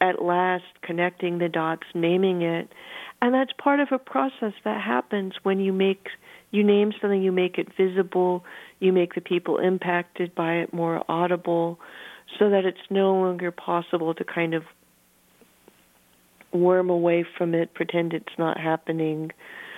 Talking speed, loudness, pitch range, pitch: 155 wpm, -24 LUFS, 170-195 Hz, 180 Hz